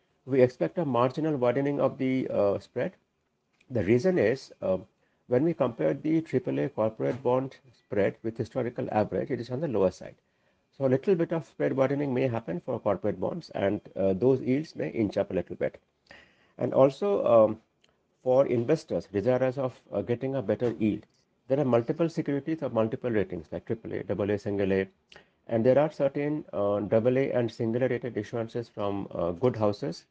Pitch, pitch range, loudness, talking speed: 125 Hz, 110-135 Hz, -28 LUFS, 180 wpm